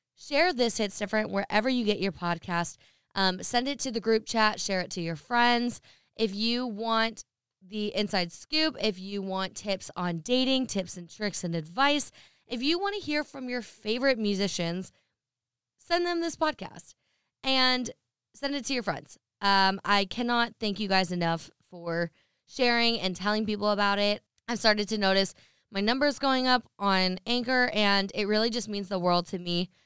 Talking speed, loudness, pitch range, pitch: 180 wpm, -28 LUFS, 190-245 Hz, 210 Hz